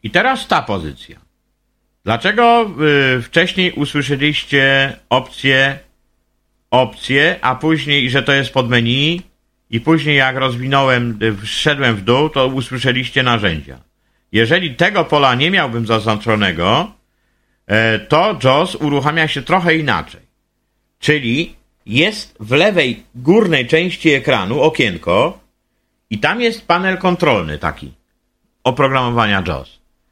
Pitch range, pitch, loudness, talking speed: 120-160 Hz, 135 Hz, -14 LUFS, 110 wpm